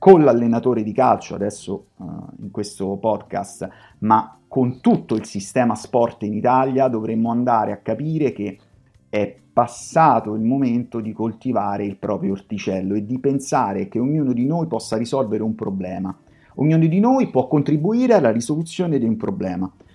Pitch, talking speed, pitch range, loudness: 115 Hz, 155 wpm, 105-135 Hz, -20 LUFS